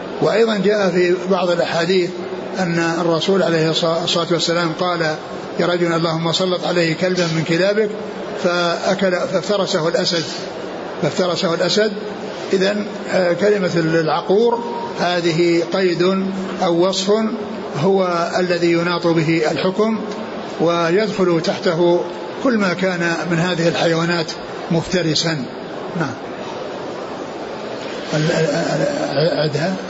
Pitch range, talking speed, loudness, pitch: 170-195 Hz, 90 wpm, -18 LUFS, 180 Hz